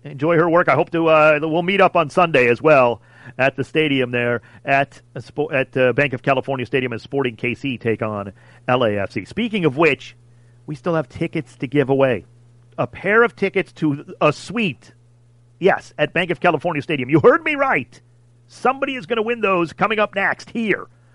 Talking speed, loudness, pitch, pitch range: 200 wpm, -19 LUFS, 145 Hz, 120-175 Hz